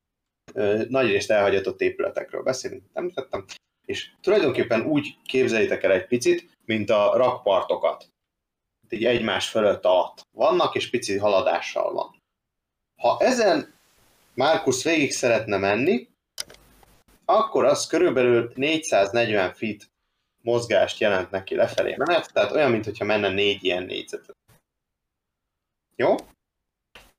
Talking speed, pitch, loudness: 110 wpm, 130 Hz, -23 LUFS